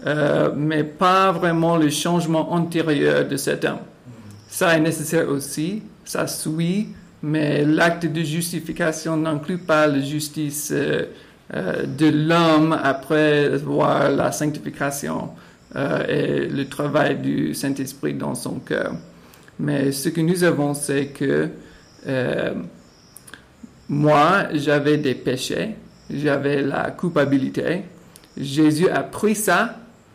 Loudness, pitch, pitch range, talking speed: -21 LUFS, 155 Hz, 145-170 Hz, 115 wpm